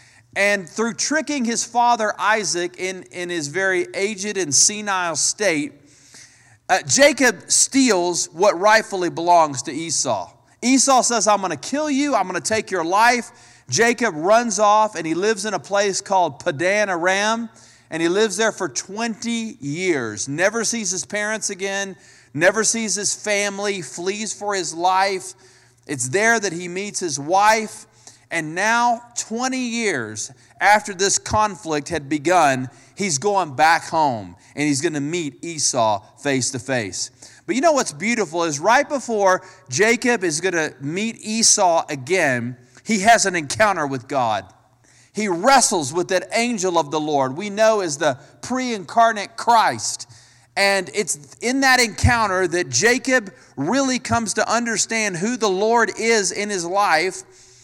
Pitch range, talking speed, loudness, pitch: 155-220 Hz, 155 wpm, -19 LUFS, 190 Hz